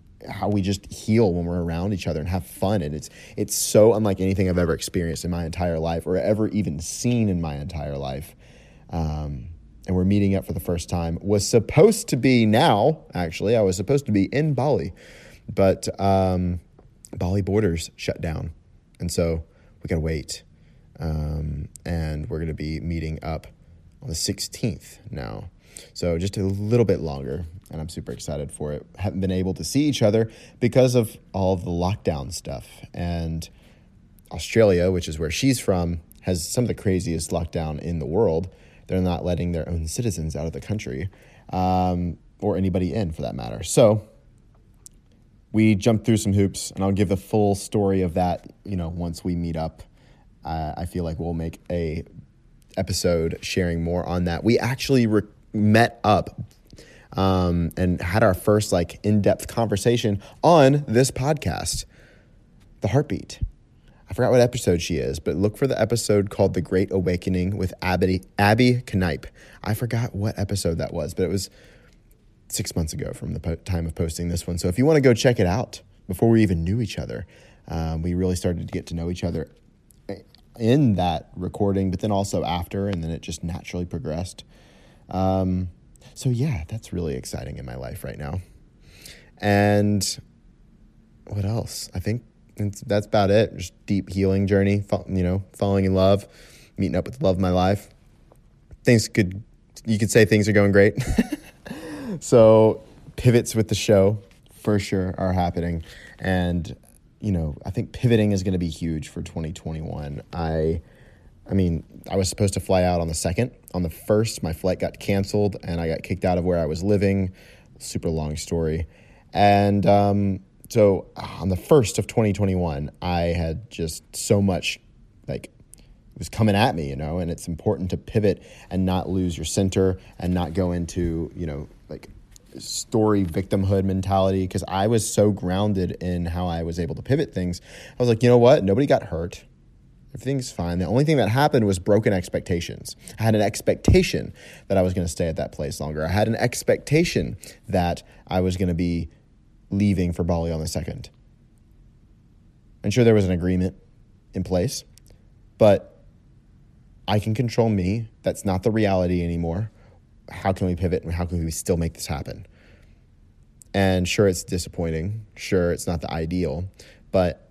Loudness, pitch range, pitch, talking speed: -23 LUFS, 85-105 Hz, 95 Hz, 180 wpm